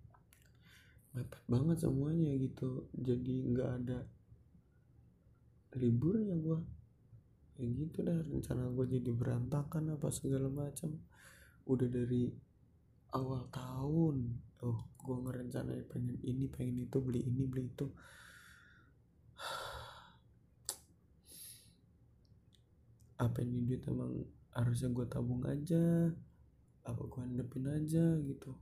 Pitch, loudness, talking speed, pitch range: 125 Hz, -38 LUFS, 100 wpm, 120-140 Hz